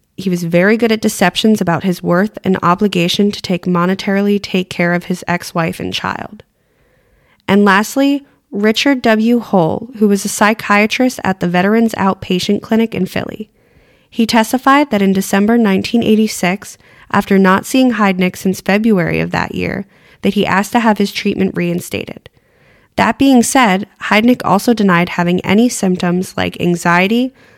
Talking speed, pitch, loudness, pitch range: 155 wpm, 200 Hz, -13 LUFS, 185-225 Hz